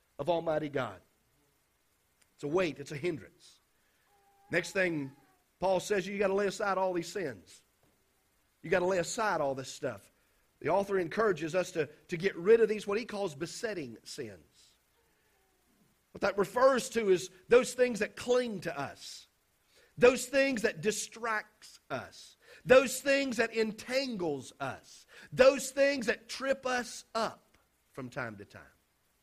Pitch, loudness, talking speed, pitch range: 200 Hz, -31 LUFS, 155 wpm, 170-245 Hz